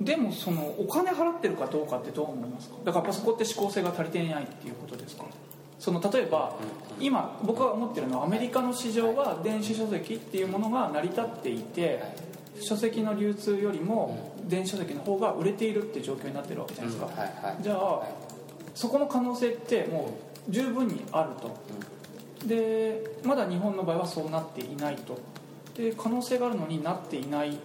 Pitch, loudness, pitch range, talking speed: 210 Hz, -30 LUFS, 170-230 Hz, 400 characters per minute